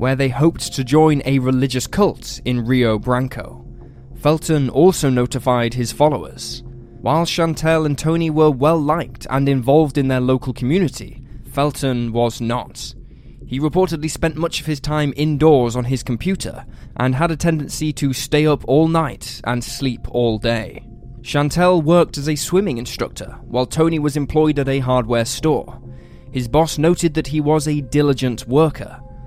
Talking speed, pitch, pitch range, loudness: 160 wpm, 135 Hz, 125-155 Hz, -18 LUFS